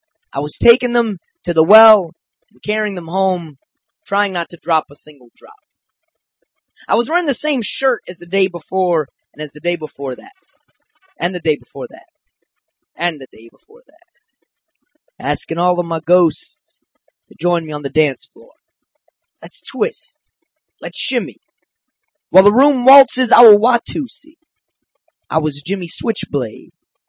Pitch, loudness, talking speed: 195 Hz, -15 LUFS, 160 wpm